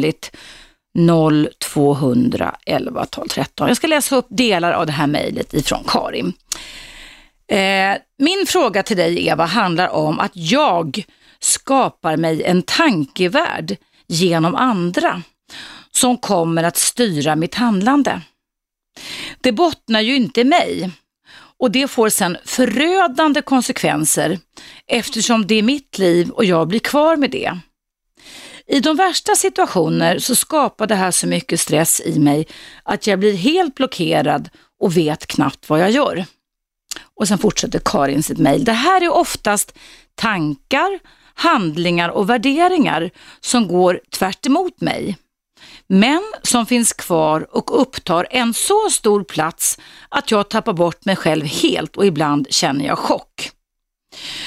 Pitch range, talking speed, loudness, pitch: 170-265 Hz, 135 wpm, -16 LUFS, 210 Hz